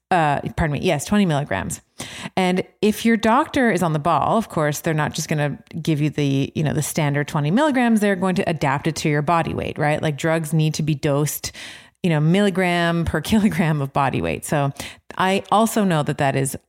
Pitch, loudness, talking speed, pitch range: 160 Hz, -20 LUFS, 220 wpm, 145-190 Hz